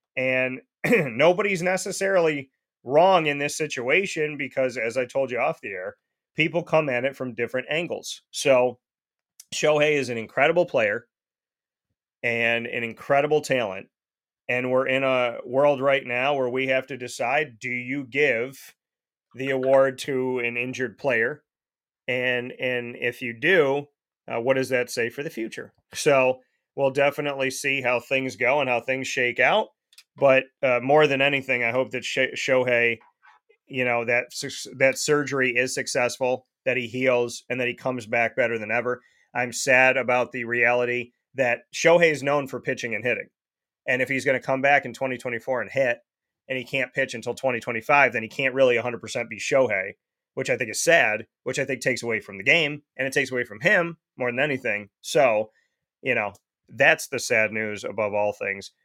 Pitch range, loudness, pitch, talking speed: 120-140 Hz, -23 LUFS, 130 Hz, 180 wpm